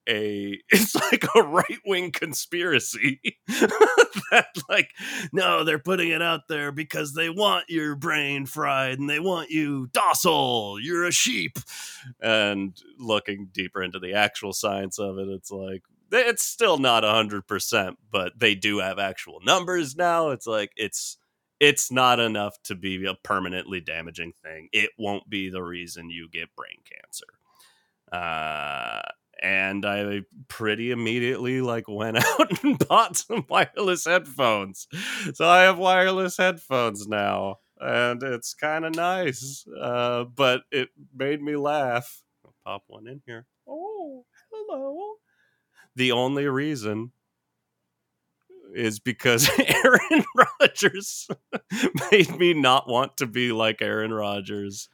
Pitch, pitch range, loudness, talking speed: 125 Hz, 100-165 Hz, -23 LUFS, 140 wpm